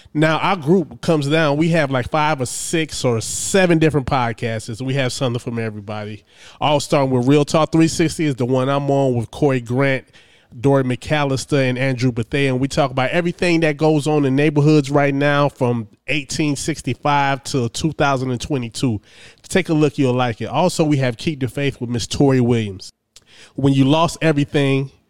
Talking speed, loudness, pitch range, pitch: 180 wpm, -18 LUFS, 125-155 Hz, 140 Hz